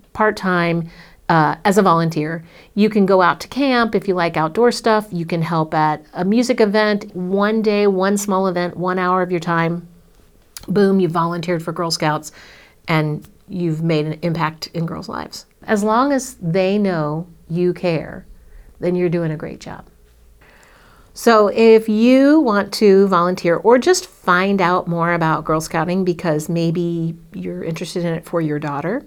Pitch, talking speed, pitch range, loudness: 175 Hz, 175 wpm, 165-200 Hz, -17 LUFS